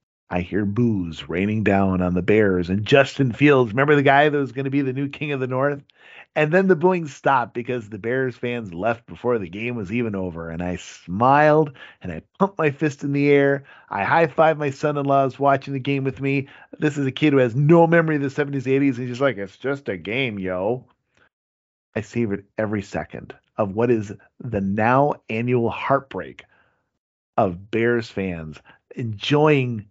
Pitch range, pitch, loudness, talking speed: 105-140 Hz, 125 Hz, -21 LUFS, 195 wpm